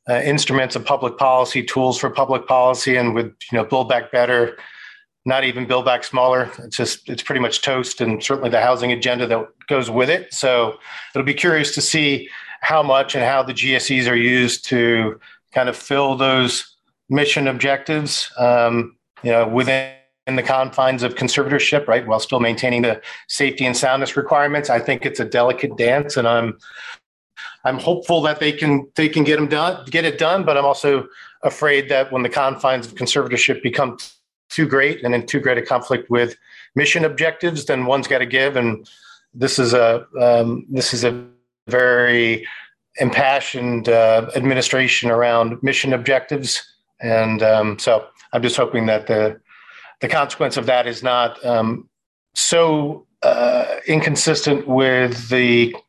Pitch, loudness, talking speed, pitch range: 130 Hz, -18 LUFS, 170 wpm, 120-140 Hz